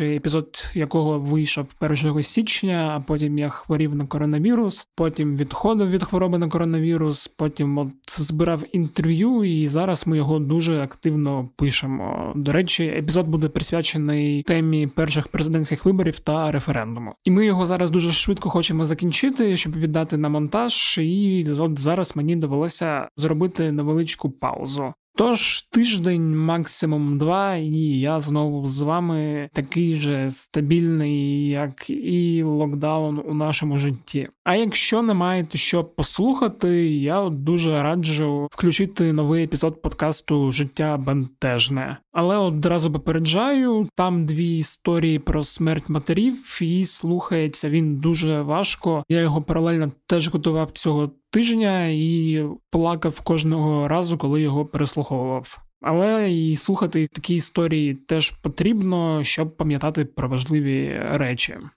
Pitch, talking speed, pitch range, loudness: 160 Hz, 130 wpm, 150-175 Hz, -22 LUFS